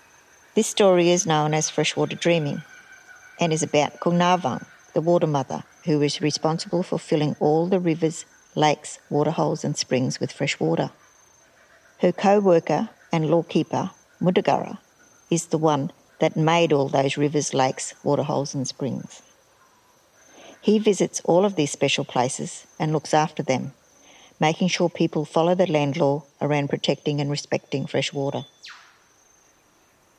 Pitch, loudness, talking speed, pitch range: 160 Hz, -23 LUFS, 140 wpm, 145-175 Hz